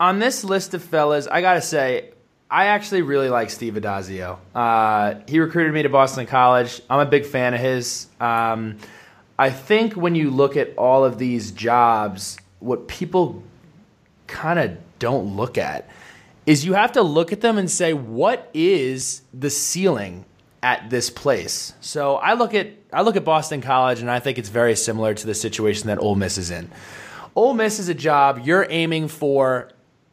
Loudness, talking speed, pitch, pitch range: -20 LUFS, 185 wpm, 135 Hz, 115-170 Hz